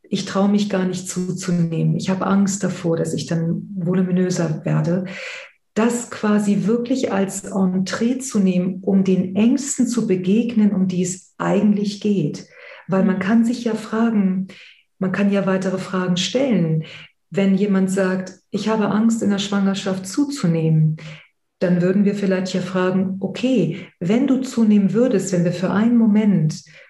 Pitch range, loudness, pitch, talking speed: 185-210 Hz, -19 LUFS, 190 Hz, 155 wpm